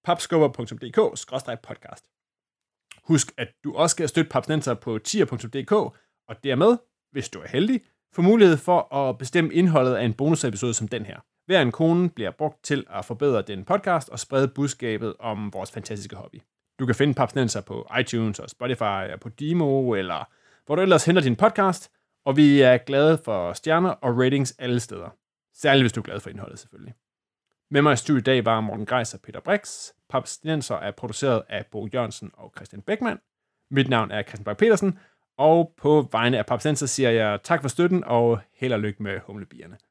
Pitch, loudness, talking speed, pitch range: 135 Hz, -23 LUFS, 185 wpm, 115-160 Hz